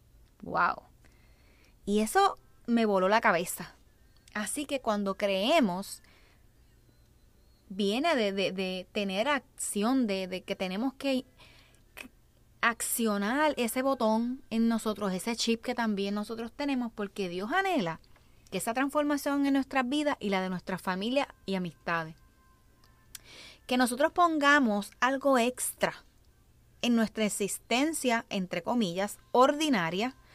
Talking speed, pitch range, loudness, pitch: 120 wpm, 200-265 Hz, -29 LUFS, 230 Hz